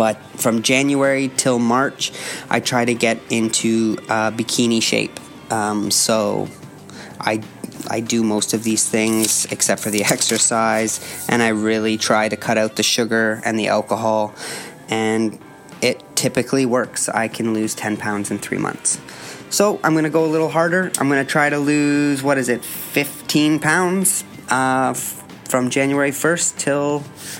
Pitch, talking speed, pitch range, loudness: 115 Hz, 160 wpm, 110-140 Hz, -18 LUFS